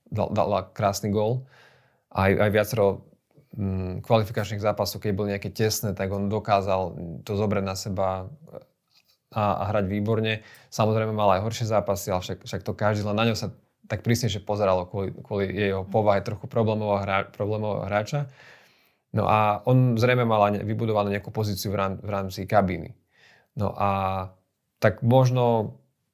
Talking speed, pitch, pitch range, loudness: 155 wpm, 105 Hz, 100-110 Hz, -25 LUFS